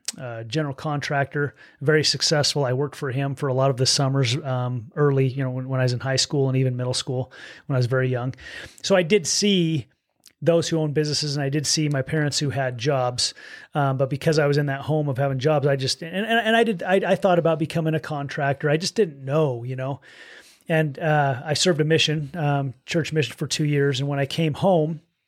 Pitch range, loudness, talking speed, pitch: 135-155 Hz, -22 LUFS, 235 wpm, 145 Hz